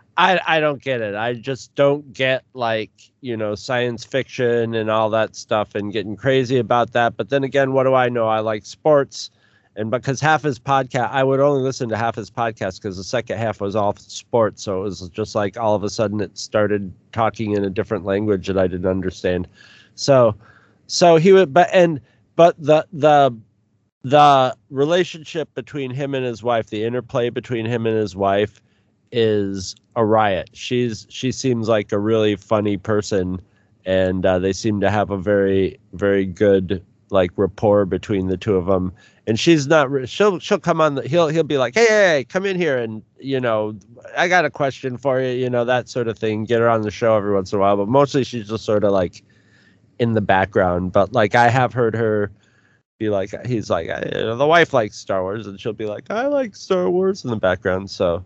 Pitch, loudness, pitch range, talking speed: 110 Hz, -19 LUFS, 105-130 Hz, 215 wpm